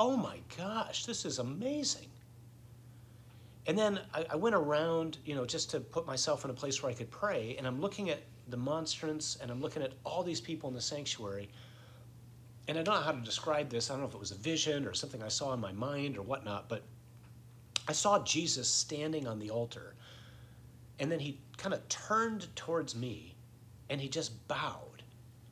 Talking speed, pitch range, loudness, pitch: 200 wpm, 120-155 Hz, -36 LUFS, 125 Hz